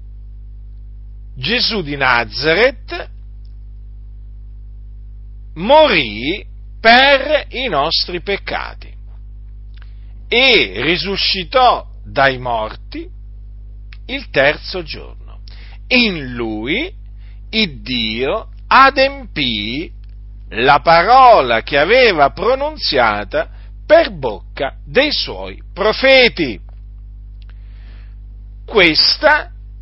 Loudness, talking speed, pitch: -13 LUFS, 60 wpm, 100 Hz